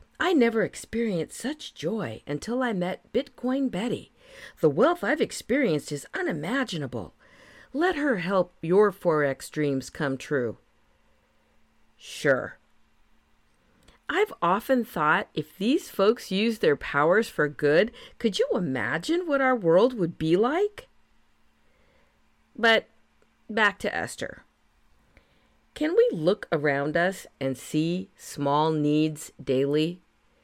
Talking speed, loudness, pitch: 115 wpm, -26 LUFS, 195 Hz